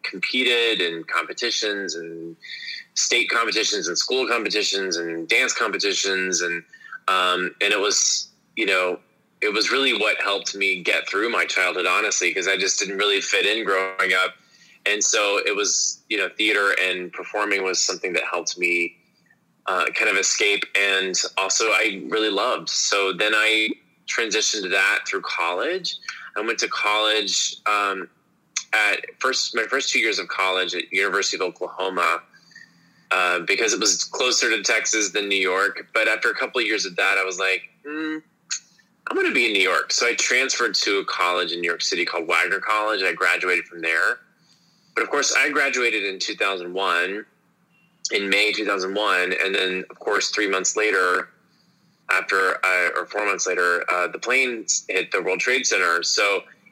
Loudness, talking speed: -21 LUFS, 175 wpm